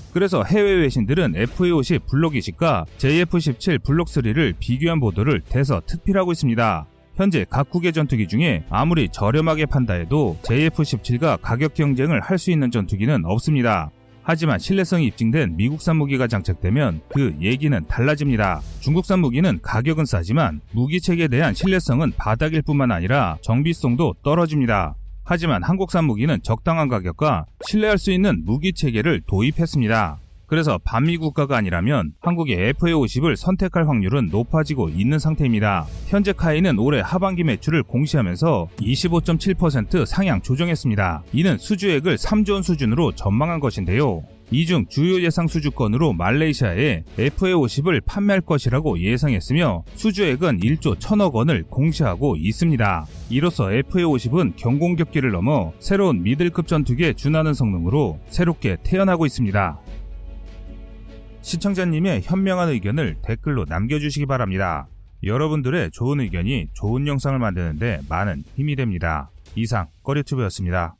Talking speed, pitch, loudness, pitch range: 345 characters per minute, 140 Hz, -20 LUFS, 110-165 Hz